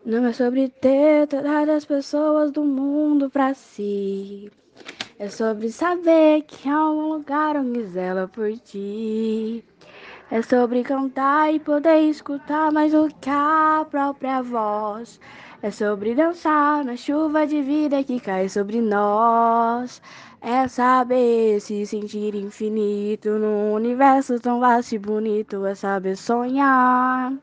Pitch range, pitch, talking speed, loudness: 215-290 Hz, 250 Hz, 130 wpm, -21 LUFS